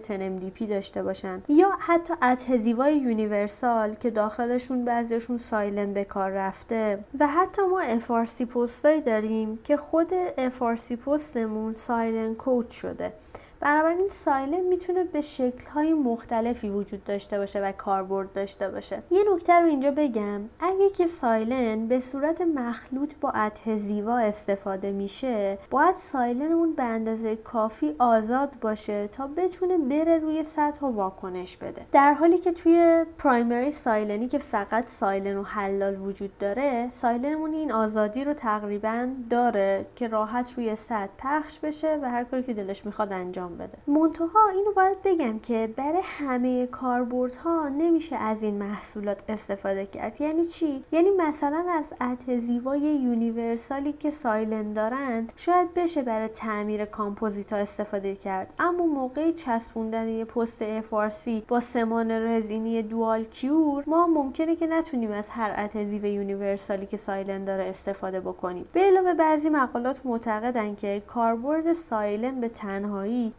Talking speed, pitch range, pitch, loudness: 145 wpm, 215-295 Hz, 235 Hz, -26 LUFS